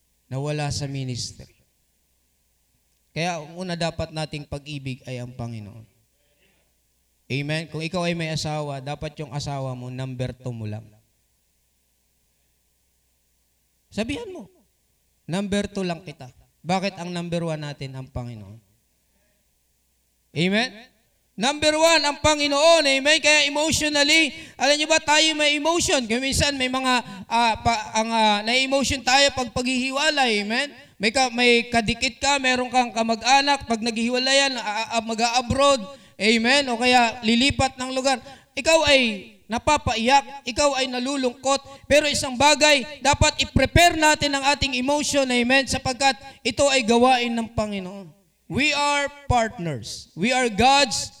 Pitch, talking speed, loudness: 230 Hz, 135 wpm, -21 LUFS